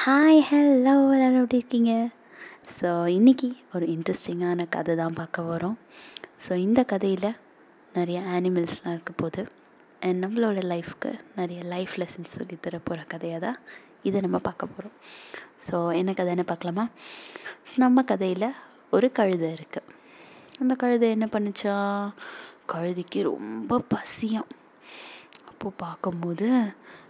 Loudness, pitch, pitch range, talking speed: -25 LUFS, 190 Hz, 175-240 Hz, 115 wpm